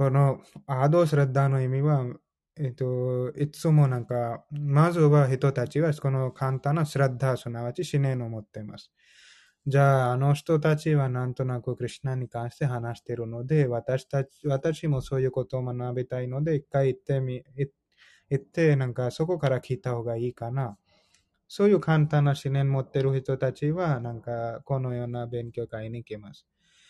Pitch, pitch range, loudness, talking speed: 135 Hz, 125-145 Hz, -27 LUFS, 350 characters per minute